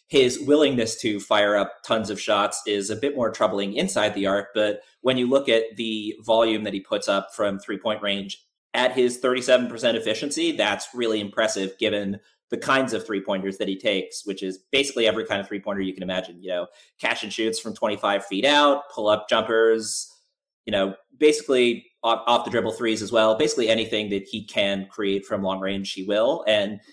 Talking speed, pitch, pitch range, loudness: 205 wpm, 110 Hz, 100-125 Hz, -23 LUFS